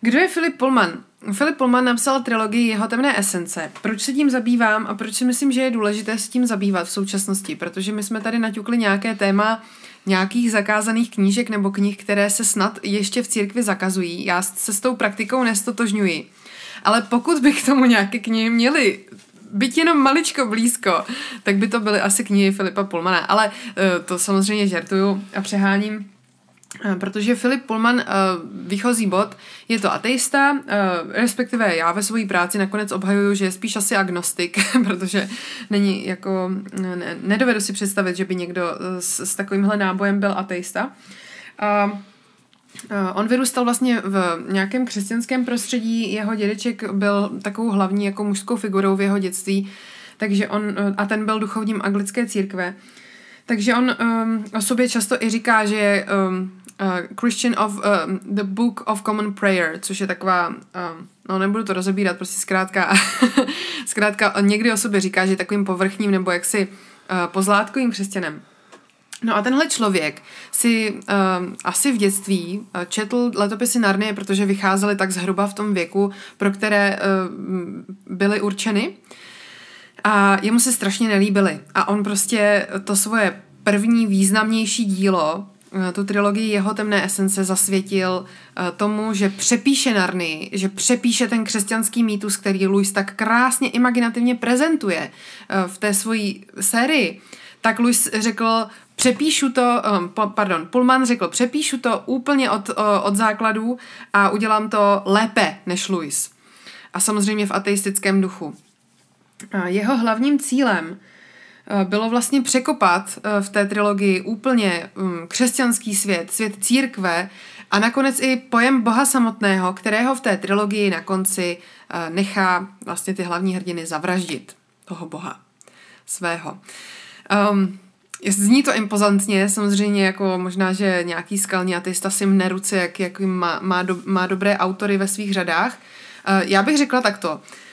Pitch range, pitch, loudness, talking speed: 195-230 Hz, 205 Hz, -19 LUFS, 150 wpm